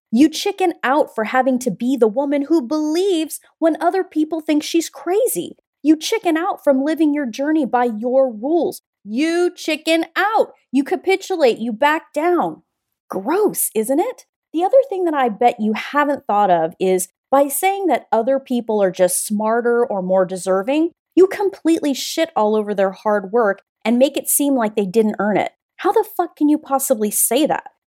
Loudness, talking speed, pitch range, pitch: -18 LUFS, 185 wpm, 230-335 Hz, 285 Hz